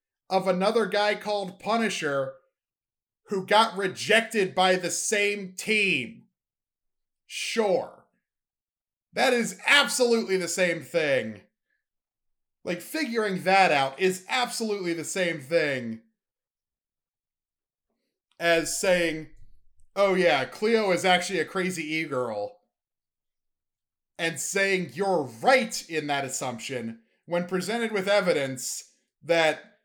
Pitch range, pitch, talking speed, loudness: 155-210 Hz, 185 Hz, 105 wpm, -25 LUFS